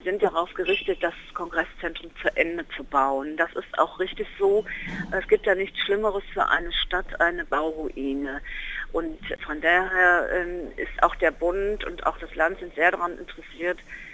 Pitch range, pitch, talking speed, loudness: 165-200 Hz, 180 Hz, 165 wpm, -25 LUFS